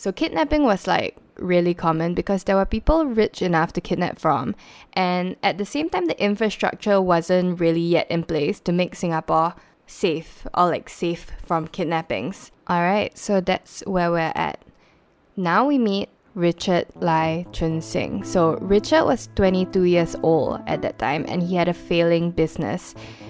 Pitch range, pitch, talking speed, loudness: 170-200 Hz, 180 Hz, 165 wpm, -22 LUFS